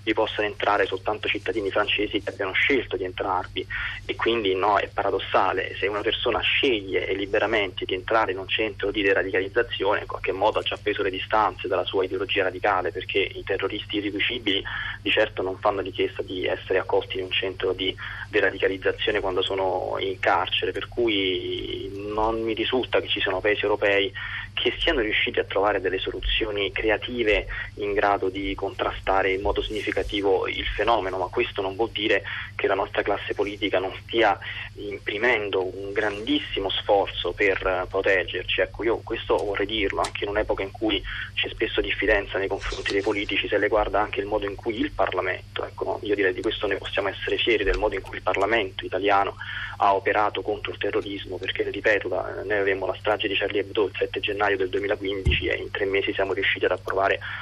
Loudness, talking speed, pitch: -24 LUFS, 185 wpm, 365 Hz